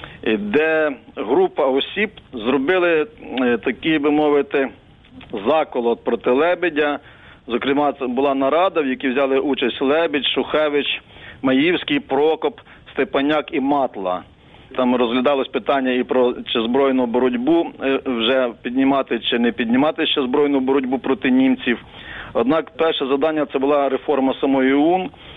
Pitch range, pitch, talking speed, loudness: 130-155 Hz, 140 Hz, 120 wpm, -19 LUFS